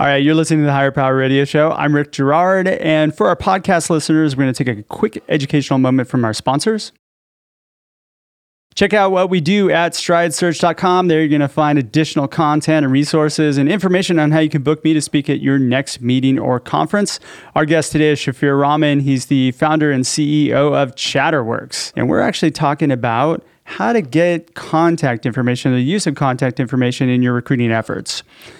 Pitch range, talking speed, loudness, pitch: 135-165 Hz, 195 wpm, -15 LUFS, 150 Hz